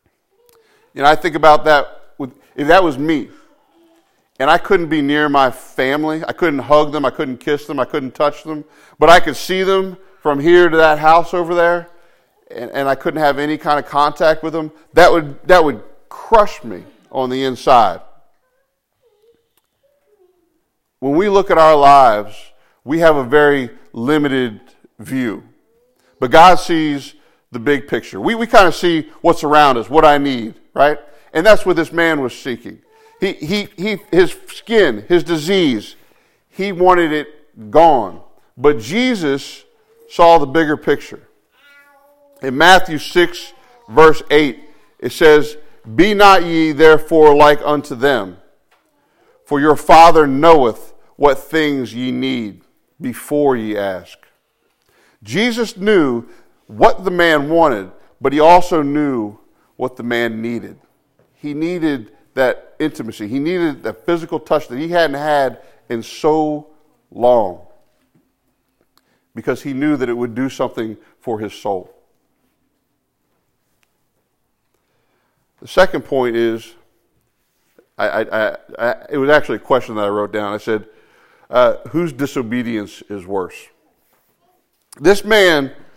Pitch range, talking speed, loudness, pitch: 135-175 Hz, 145 wpm, -14 LUFS, 155 Hz